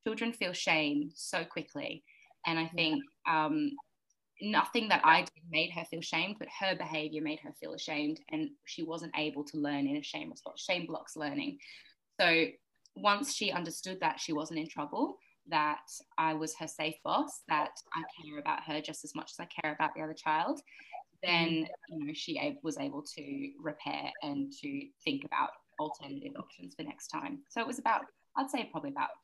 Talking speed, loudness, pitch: 190 wpm, -34 LUFS, 165 Hz